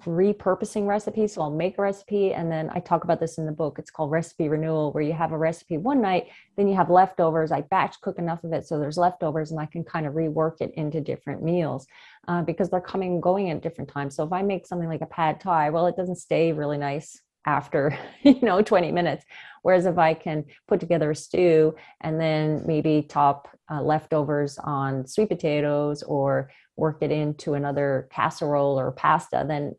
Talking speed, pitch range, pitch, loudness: 210 wpm, 150-180 Hz, 160 Hz, -25 LUFS